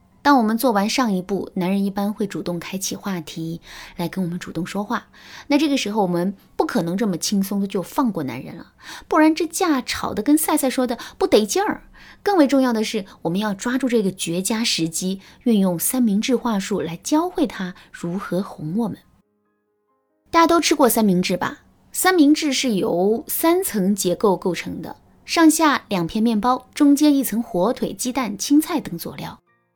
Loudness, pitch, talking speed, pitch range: -20 LUFS, 220 Hz, 275 characters per minute, 185-275 Hz